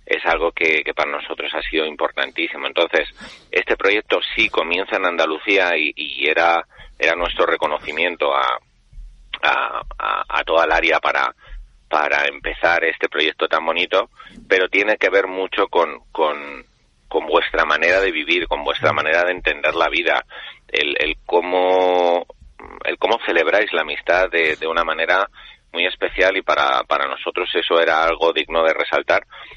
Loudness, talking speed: -18 LUFS, 160 wpm